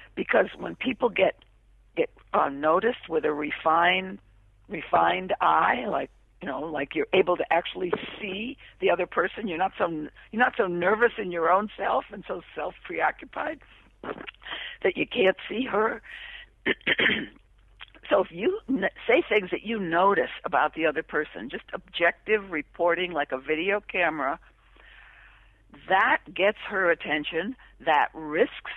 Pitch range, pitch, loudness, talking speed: 160-220 Hz, 185 Hz, -26 LUFS, 140 wpm